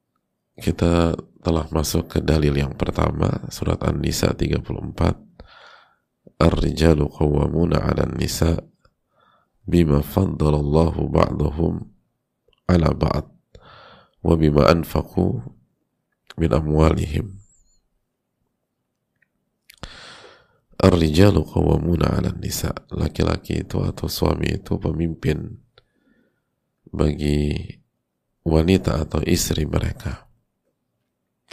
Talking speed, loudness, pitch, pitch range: 75 wpm, -21 LUFS, 80 Hz, 75-85 Hz